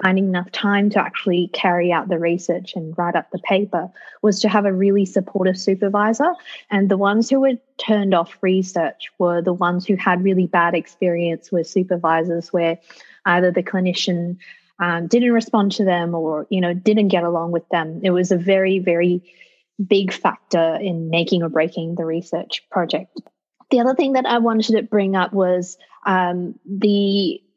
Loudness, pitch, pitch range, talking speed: -19 LUFS, 185 Hz, 175-200 Hz, 180 wpm